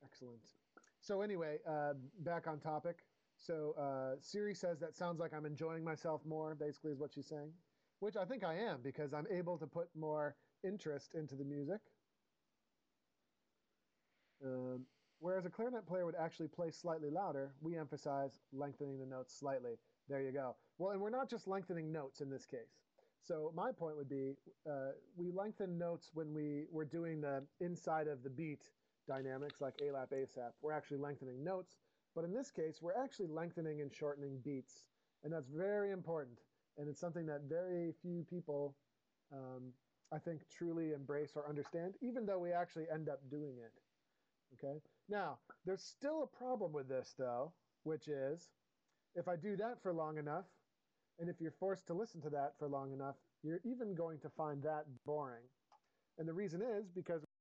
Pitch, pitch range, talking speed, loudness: 155 Hz, 145-175 Hz, 180 wpm, -45 LUFS